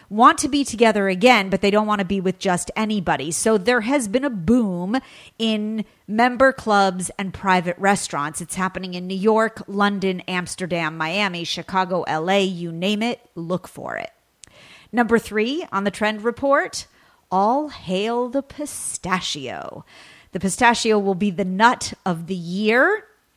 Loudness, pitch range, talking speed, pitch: -21 LUFS, 185-235 Hz, 155 wpm, 205 Hz